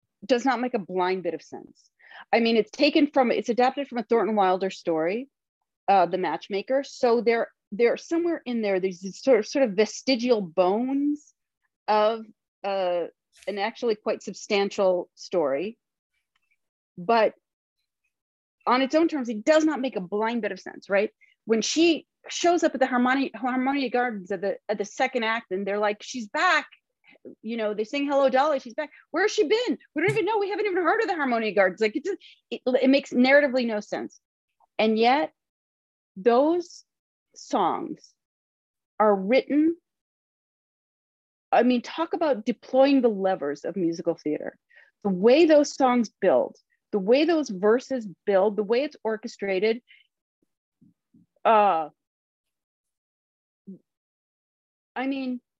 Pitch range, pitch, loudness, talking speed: 205-275 Hz, 240 Hz, -24 LUFS, 155 wpm